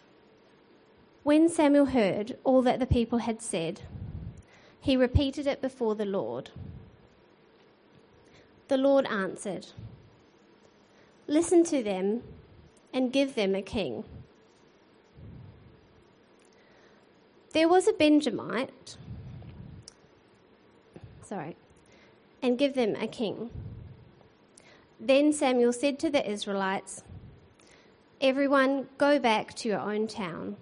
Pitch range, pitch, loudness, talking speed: 215-285 Hz, 260 Hz, -27 LUFS, 95 wpm